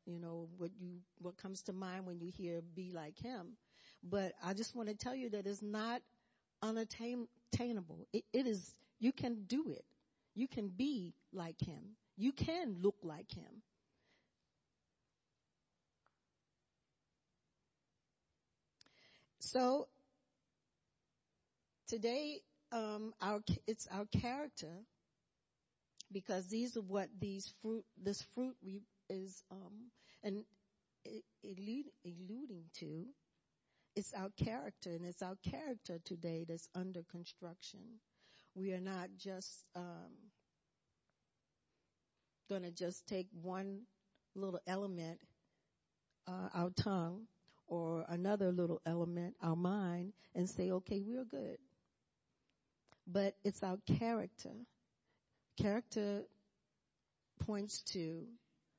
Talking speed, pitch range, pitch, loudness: 110 wpm, 180-225 Hz, 195 Hz, -44 LUFS